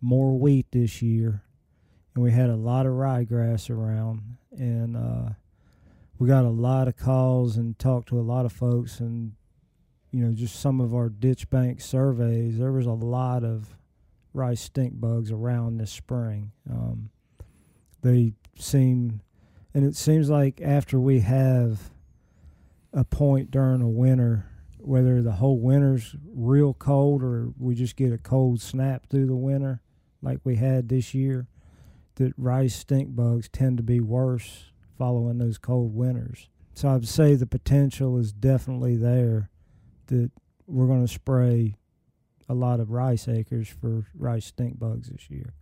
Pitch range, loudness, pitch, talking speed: 115-130 Hz, -24 LUFS, 120 Hz, 155 wpm